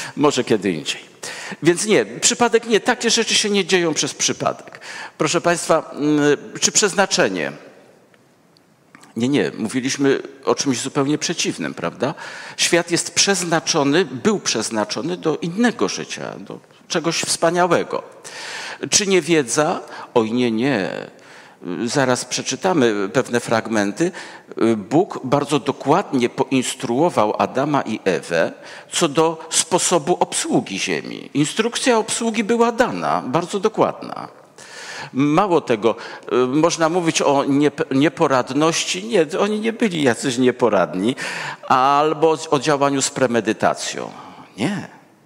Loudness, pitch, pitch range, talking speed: -19 LUFS, 160 Hz, 135-190 Hz, 110 wpm